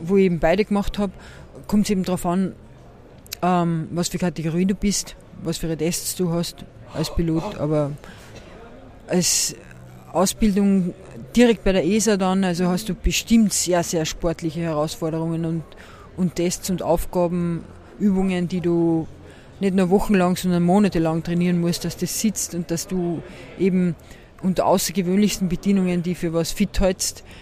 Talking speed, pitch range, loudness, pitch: 155 wpm, 165-190 Hz, -21 LUFS, 180 Hz